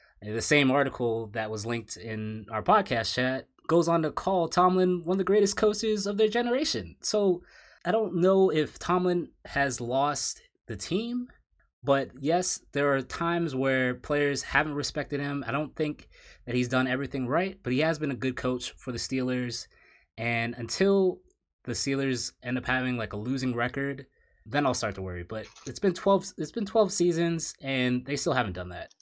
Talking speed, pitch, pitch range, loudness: 190 wpm, 140 Hz, 125-180 Hz, -28 LUFS